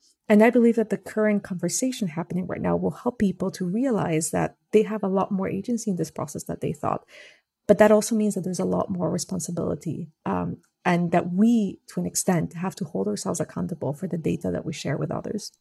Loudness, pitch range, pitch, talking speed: -25 LUFS, 175-215 Hz, 190 Hz, 225 wpm